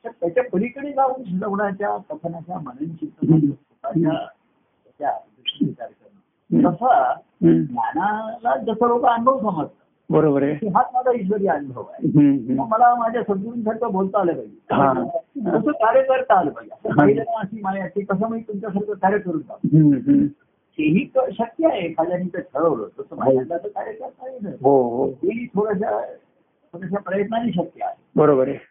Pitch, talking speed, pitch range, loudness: 210 Hz, 115 wpm, 170-240 Hz, -21 LUFS